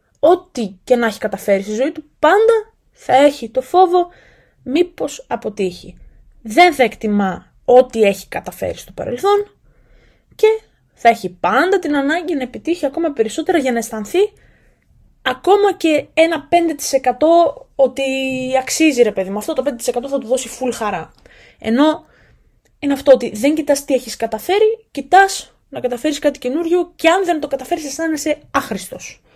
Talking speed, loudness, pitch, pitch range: 150 wpm, -16 LUFS, 280 Hz, 245-335 Hz